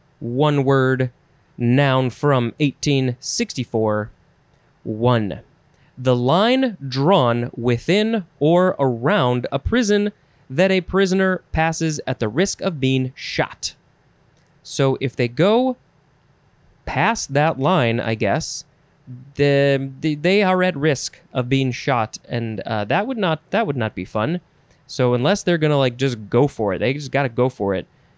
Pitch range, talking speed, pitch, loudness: 125-165 Hz, 145 wpm, 140 Hz, -20 LUFS